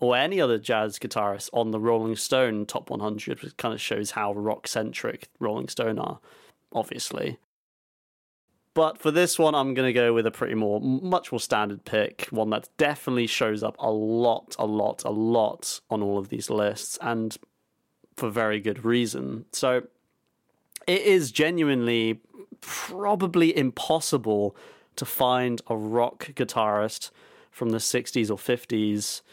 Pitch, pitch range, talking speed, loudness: 115 Hz, 105-130 Hz, 150 wpm, -26 LUFS